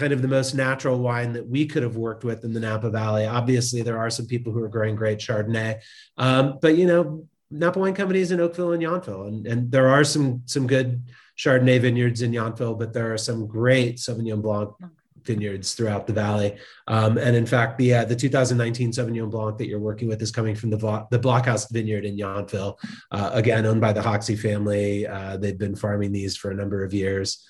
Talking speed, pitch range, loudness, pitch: 220 wpm, 110-130 Hz, -23 LUFS, 115 Hz